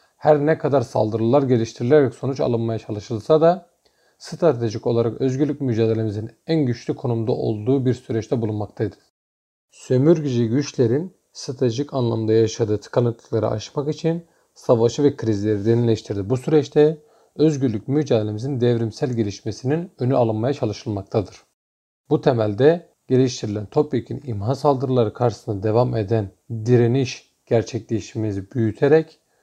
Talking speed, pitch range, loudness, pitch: 110 wpm, 110-145 Hz, -21 LUFS, 120 Hz